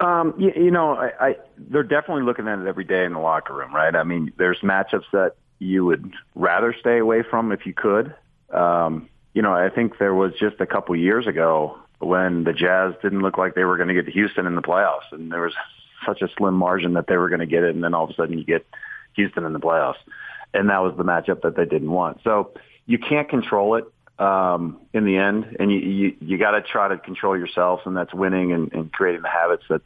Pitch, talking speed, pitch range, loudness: 95 Hz, 245 wpm, 90-105 Hz, -21 LUFS